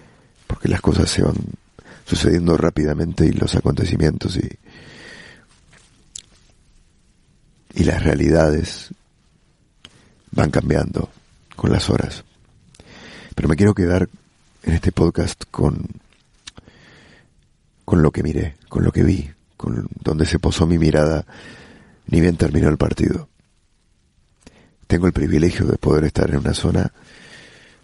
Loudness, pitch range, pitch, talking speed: -19 LUFS, 75-90 Hz, 85 Hz, 120 wpm